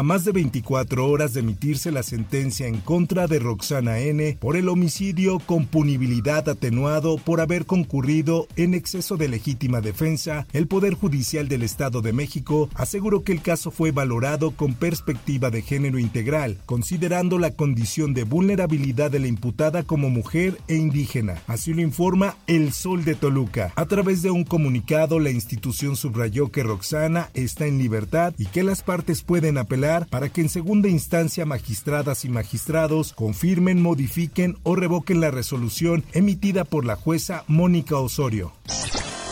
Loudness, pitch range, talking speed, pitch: -23 LUFS, 130-170 Hz, 160 wpm, 155 Hz